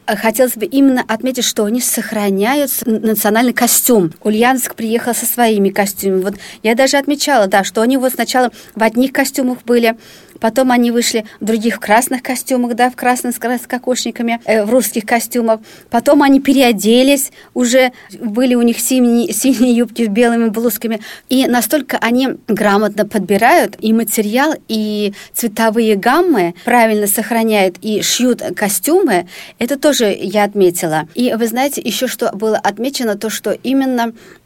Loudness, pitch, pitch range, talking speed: -14 LUFS, 235 Hz, 220-255 Hz, 150 wpm